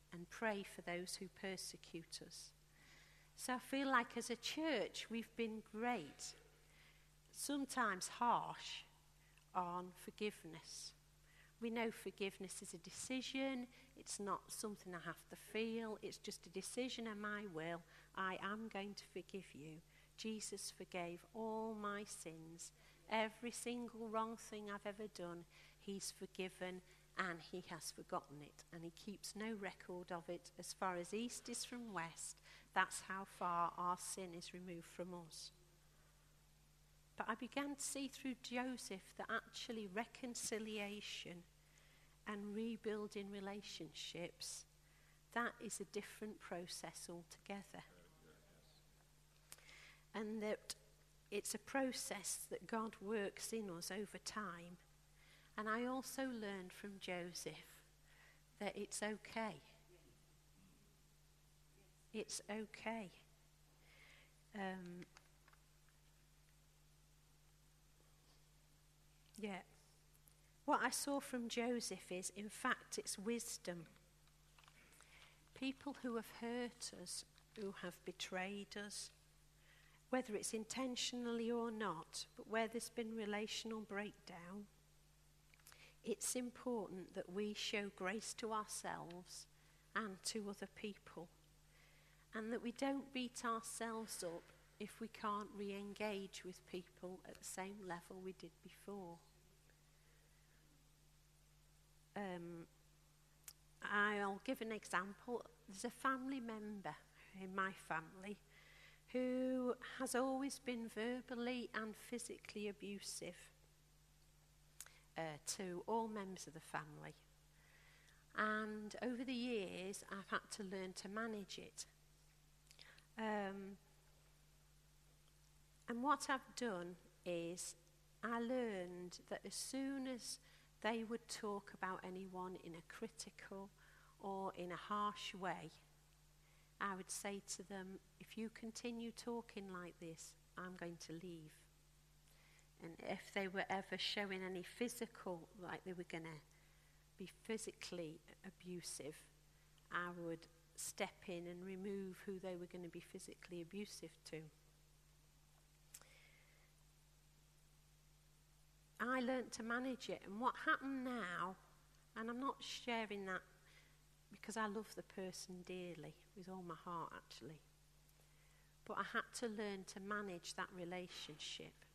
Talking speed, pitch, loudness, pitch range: 120 wpm, 190 Hz, -47 LUFS, 165-220 Hz